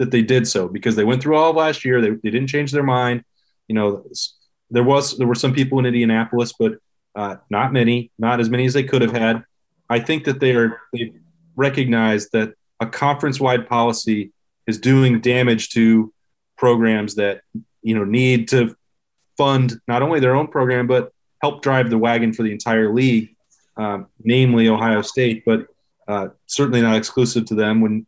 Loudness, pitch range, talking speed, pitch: -18 LUFS, 110-130 Hz, 190 wpm, 120 Hz